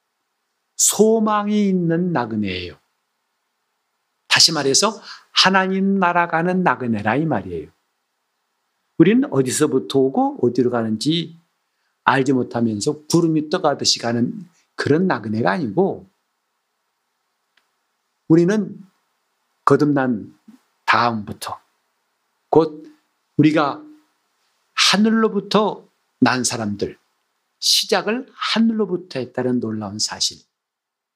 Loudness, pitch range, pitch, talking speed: -18 LUFS, 125-195 Hz, 155 Hz, 210 characters per minute